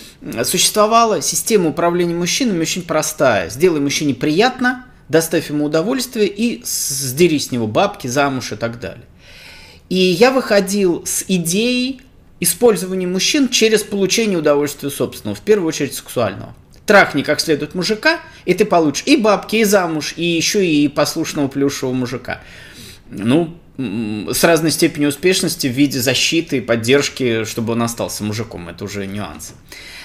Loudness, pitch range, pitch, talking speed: -16 LUFS, 130-190 Hz, 160 Hz, 140 wpm